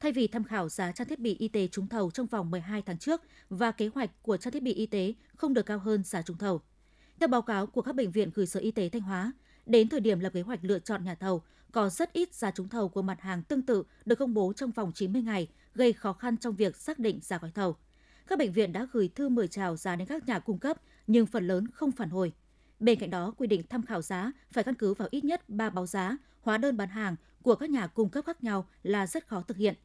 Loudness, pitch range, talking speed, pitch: -31 LUFS, 190-245 Hz, 275 wpm, 215 Hz